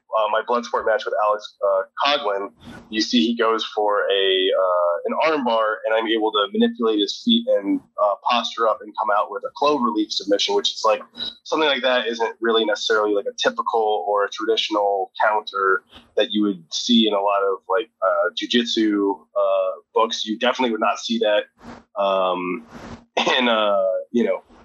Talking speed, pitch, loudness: 190 wpm, 110 Hz, -21 LUFS